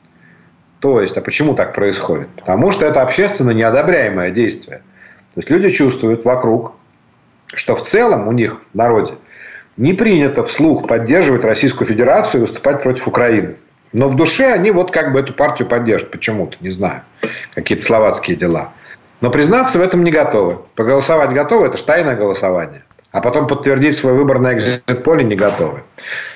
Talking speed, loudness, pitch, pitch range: 160 wpm, -14 LUFS, 135 Hz, 120-150 Hz